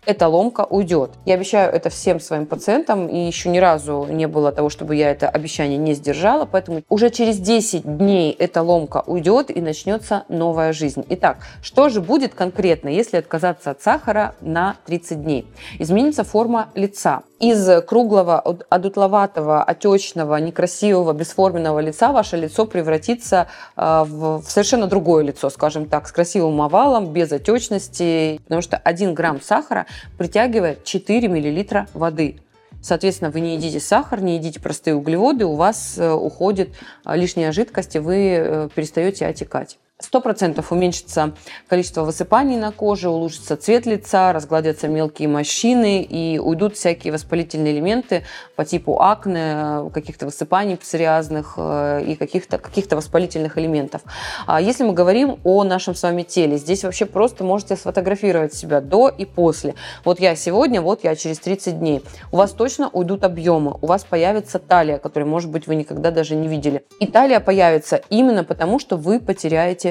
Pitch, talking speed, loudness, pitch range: 175 Hz, 150 wpm, -18 LUFS, 155-200 Hz